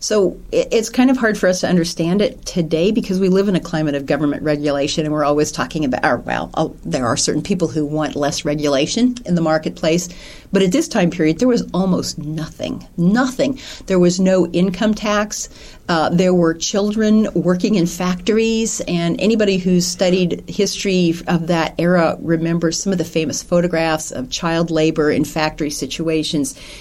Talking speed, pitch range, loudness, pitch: 175 wpm, 155-195 Hz, -17 LUFS, 175 Hz